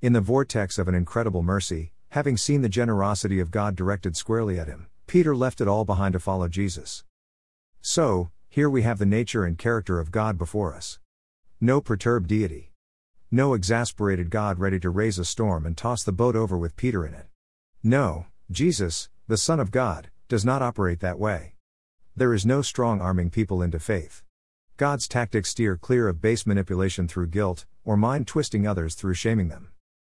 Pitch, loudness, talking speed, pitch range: 100 Hz, -25 LUFS, 185 wpm, 90-115 Hz